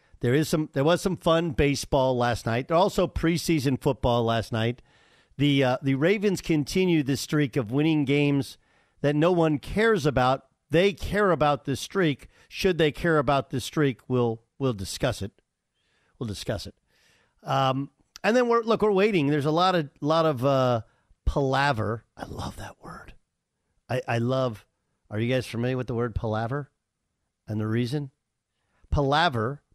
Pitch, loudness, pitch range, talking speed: 140 Hz, -25 LUFS, 120-165 Hz, 170 wpm